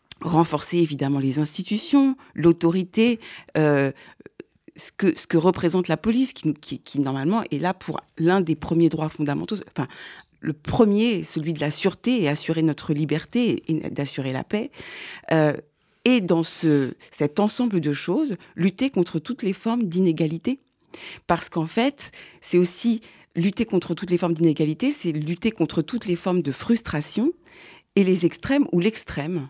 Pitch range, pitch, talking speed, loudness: 155-220 Hz, 175 Hz, 160 wpm, -23 LUFS